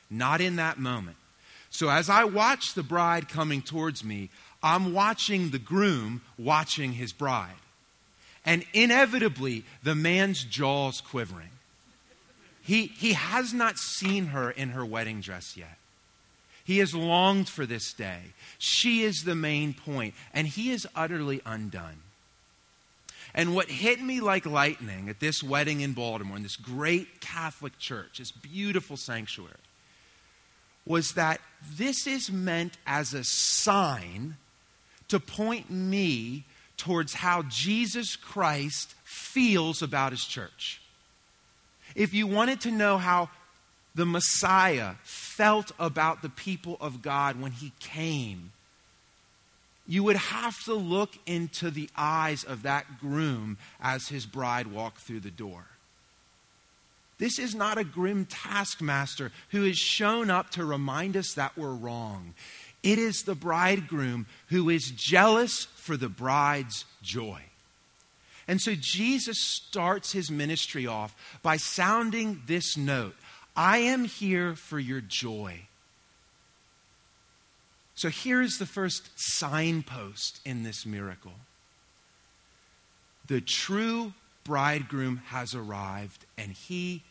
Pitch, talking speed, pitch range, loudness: 155 Hz, 125 wpm, 125-190 Hz, -28 LUFS